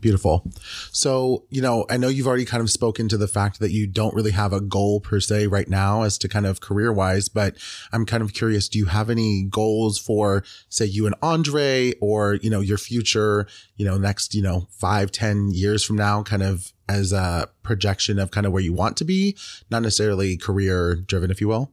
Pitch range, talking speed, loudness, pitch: 100-110 Hz, 225 wpm, -22 LUFS, 105 Hz